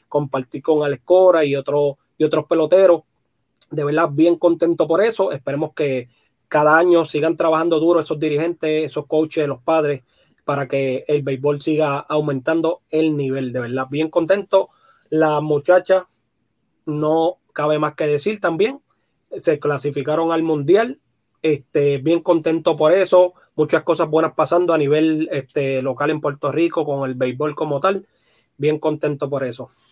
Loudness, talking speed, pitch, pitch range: -18 LUFS, 155 wpm, 155 Hz, 140-165 Hz